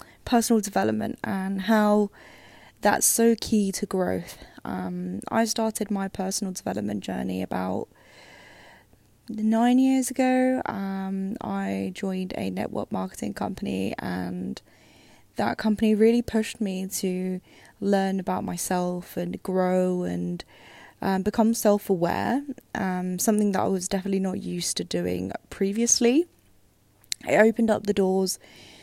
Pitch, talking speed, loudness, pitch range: 195 Hz, 125 wpm, -25 LUFS, 175-220 Hz